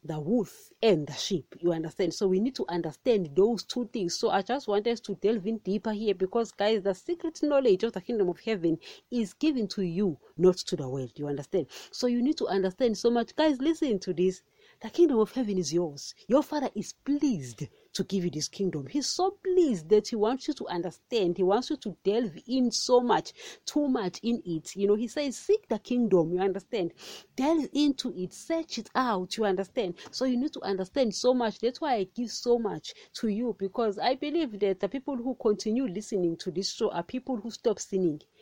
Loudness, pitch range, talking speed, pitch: -29 LUFS, 185-255 Hz, 220 wpm, 215 Hz